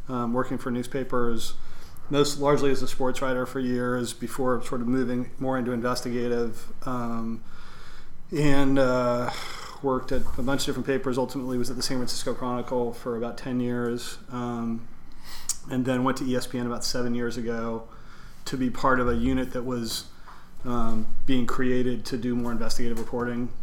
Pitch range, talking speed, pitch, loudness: 120-130 Hz, 170 wpm, 125 Hz, -28 LUFS